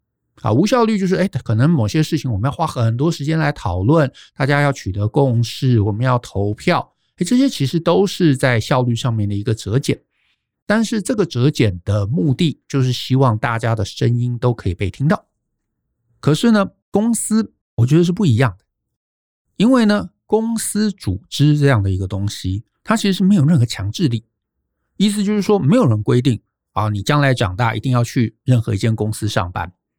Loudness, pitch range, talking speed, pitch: -17 LUFS, 110-165 Hz, 290 characters per minute, 130 Hz